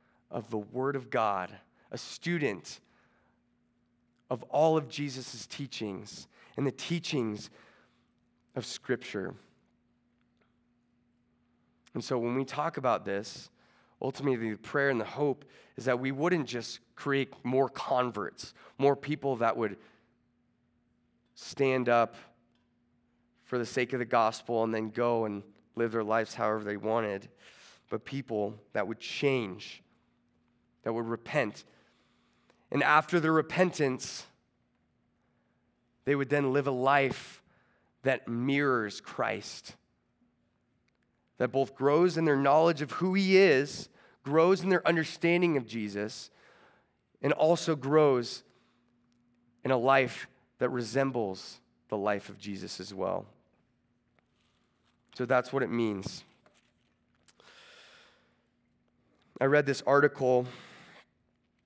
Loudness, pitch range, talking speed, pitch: -30 LUFS, 115-140 Hz, 115 wpm, 125 Hz